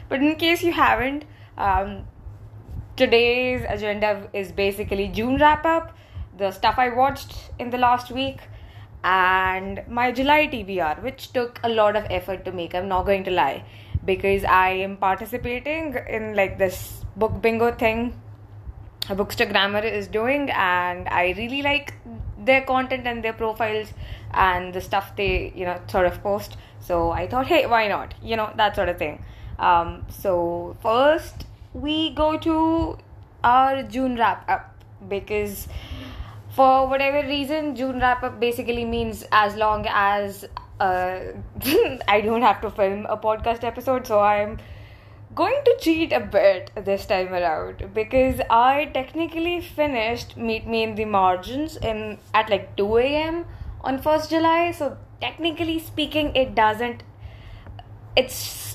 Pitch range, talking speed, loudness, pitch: 180-260 Hz, 150 wpm, -22 LUFS, 215 Hz